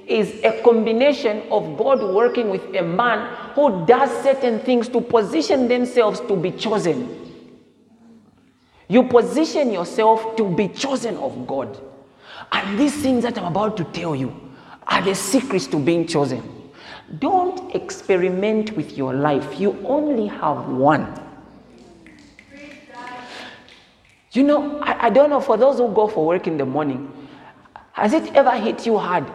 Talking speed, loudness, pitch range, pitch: 145 wpm, -19 LUFS, 185-255 Hz, 225 Hz